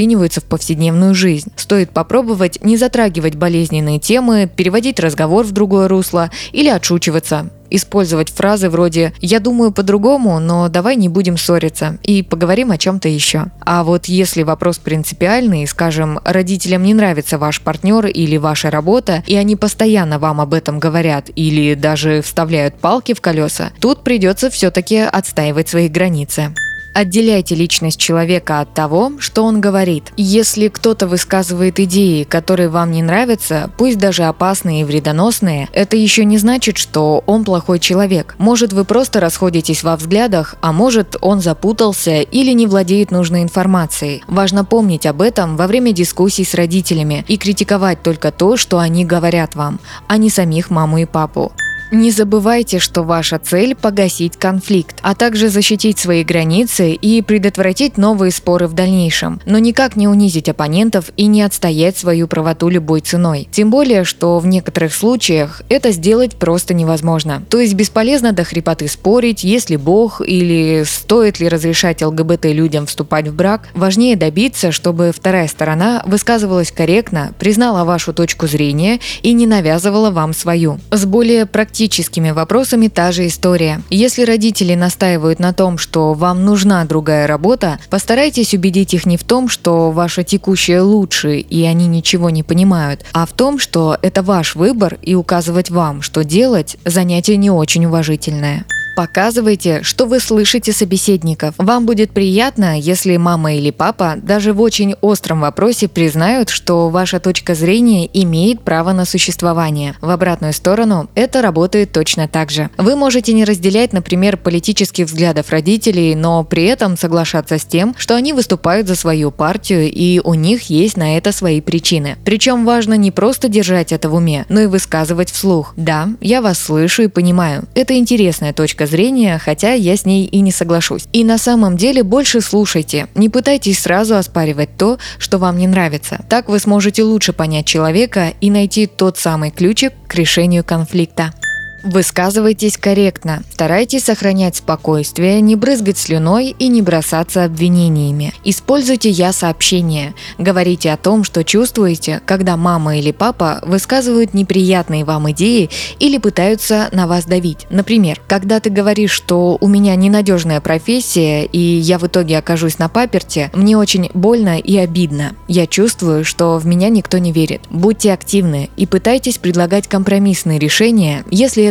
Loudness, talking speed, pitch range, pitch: -13 LUFS, 155 wpm, 165-210 Hz, 185 Hz